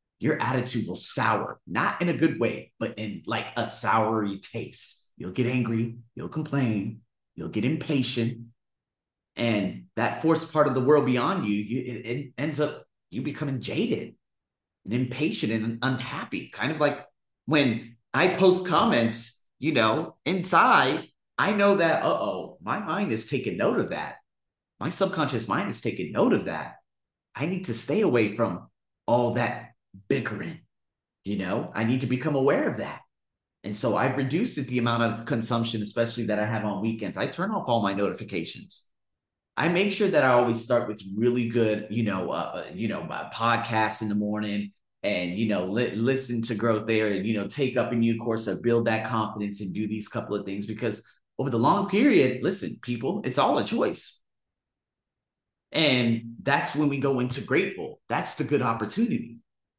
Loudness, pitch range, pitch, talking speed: -26 LUFS, 110-135 Hz, 115 Hz, 185 wpm